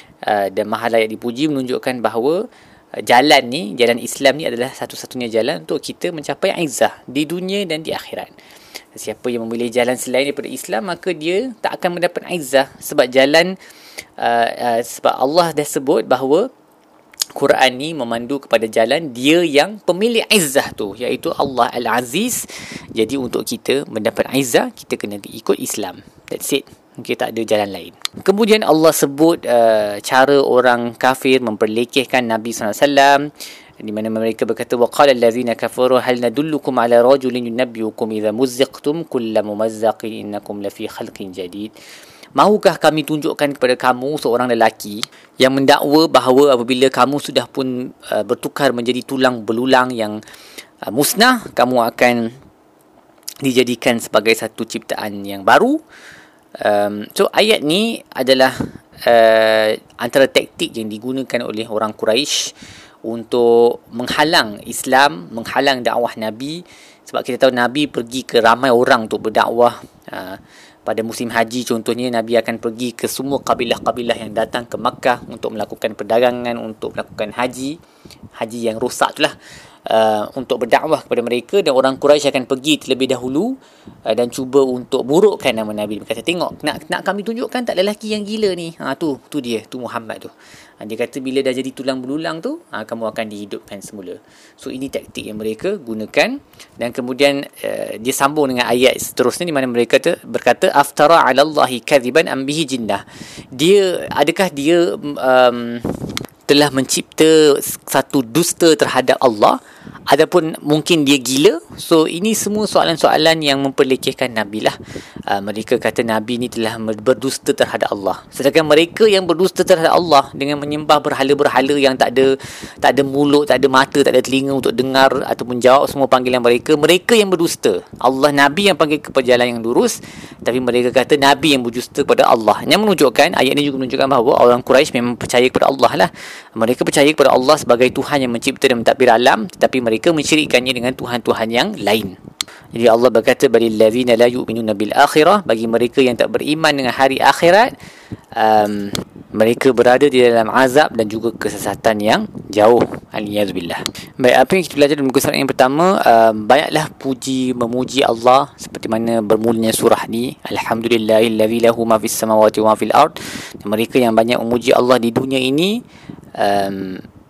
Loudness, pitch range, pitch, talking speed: -15 LUFS, 115-145 Hz, 130 Hz, 160 wpm